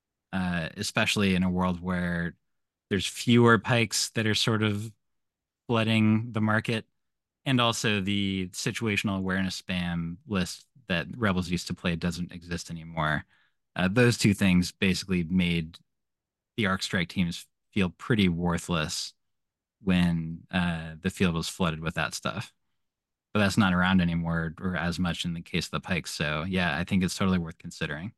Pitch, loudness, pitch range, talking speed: 90 Hz, -27 LUFS, 85-105 Hz, 160 wpm